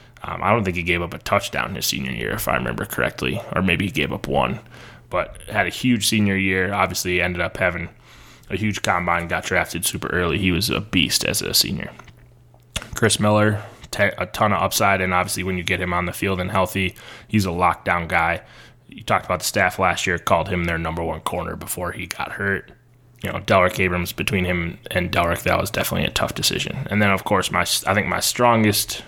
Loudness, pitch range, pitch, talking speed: -21 LUFS, 90-105 Hz, 95 Hz, 225 wpm